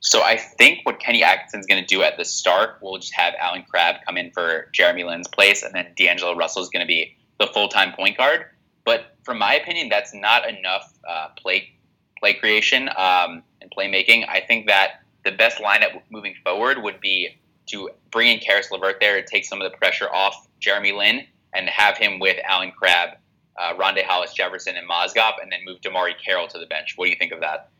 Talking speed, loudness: 215 wpm, -19 LUFS